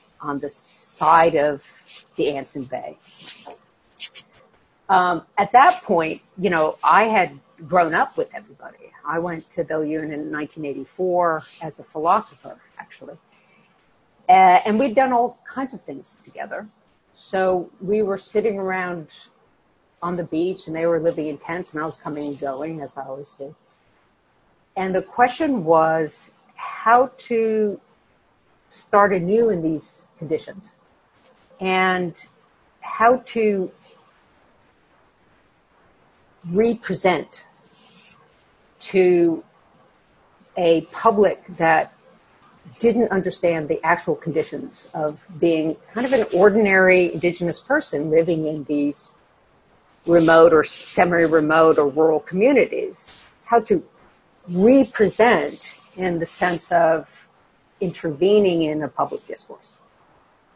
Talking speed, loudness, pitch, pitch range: 115 wpm, -20 LUFS, 175 Hz, 160-210 Hz